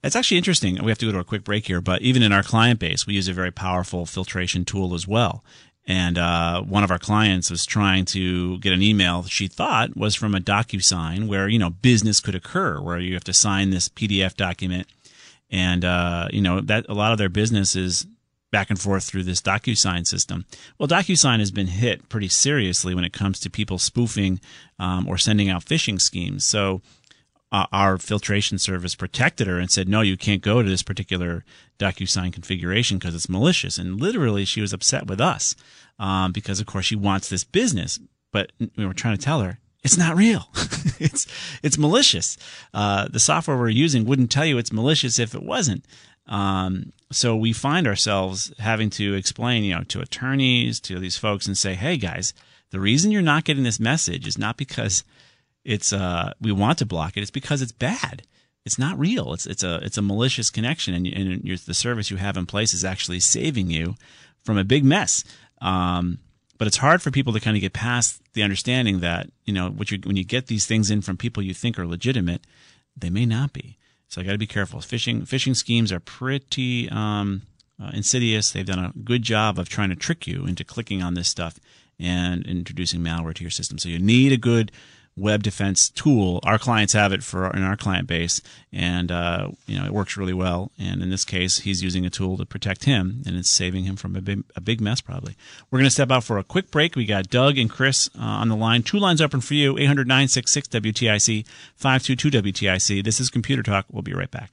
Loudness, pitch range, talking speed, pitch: -21 LUFS, 95-120 Hz, 220 wpm, 100 Hz